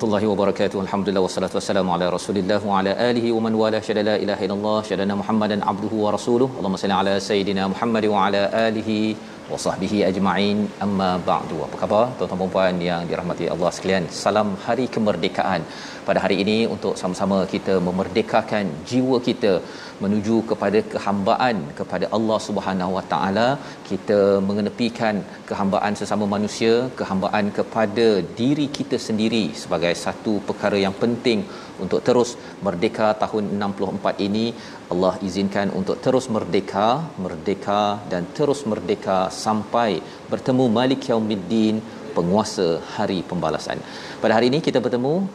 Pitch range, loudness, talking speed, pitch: 95-110 Hz, -22 LUFS, 140 wpm, 105 Hz